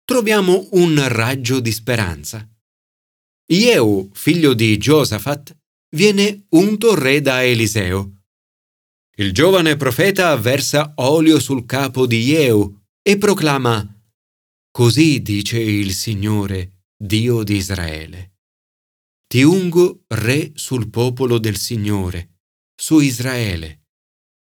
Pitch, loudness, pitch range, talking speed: 120 Hz, -16 LUFS, 100-150 Hz, 100 wpm